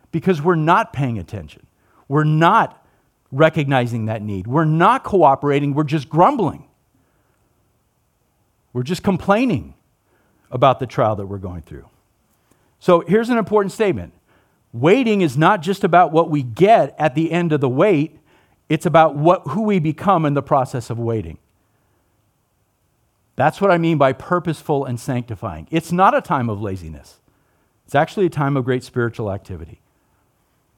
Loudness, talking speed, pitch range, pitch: -17 LUFS, 150 wpm, 115-175 Hz, 145 Hz